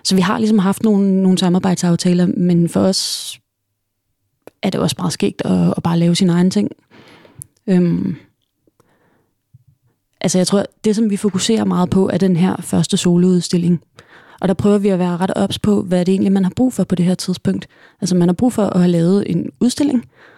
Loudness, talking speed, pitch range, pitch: -16 LUFS, 200 wpm, 175-200 Hz, 185 Hz